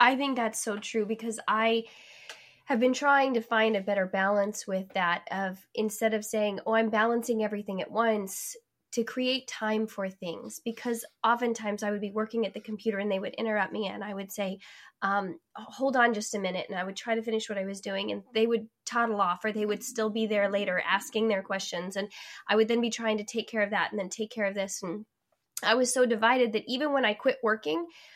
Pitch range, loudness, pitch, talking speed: 200-230 Hz, -29 LUFS, 215 Hz, 230 wpm